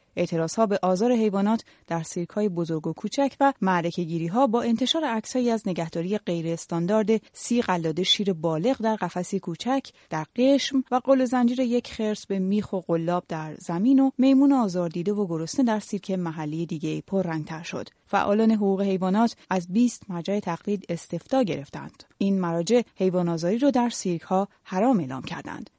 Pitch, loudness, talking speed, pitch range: 195 Hz, -25 LUFS, 170 wpm, 170-235 Hz